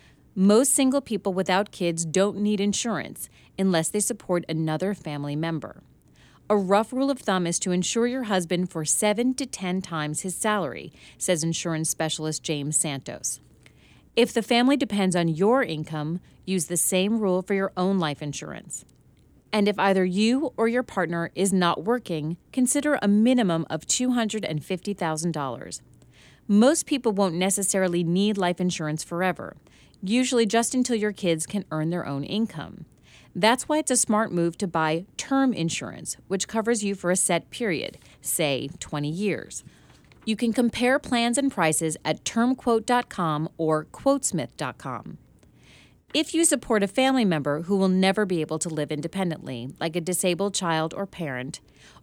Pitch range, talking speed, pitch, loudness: 165-225 Hz, 155 wpm, 190 Hz, -25 LUFS